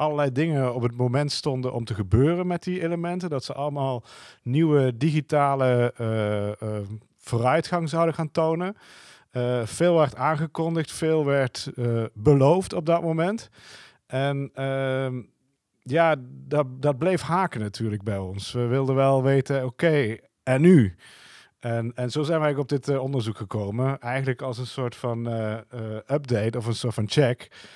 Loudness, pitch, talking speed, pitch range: -25 LUFS, 135 Hz, 160 wpm, 120-155 Hz